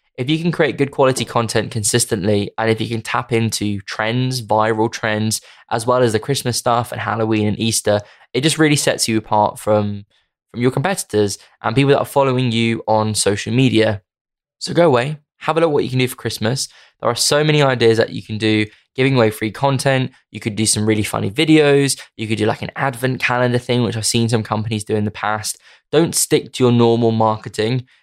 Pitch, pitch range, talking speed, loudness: 115 Hz, 110-130 Hz, 220 wpm, -17 LUFS